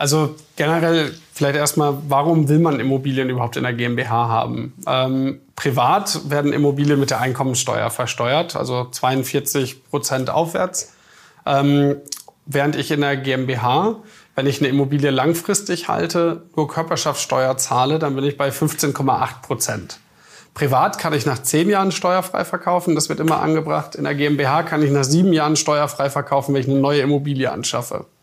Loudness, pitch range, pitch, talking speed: -19 LUFS, 135-155 Hz, 145 Hz, 155 wpm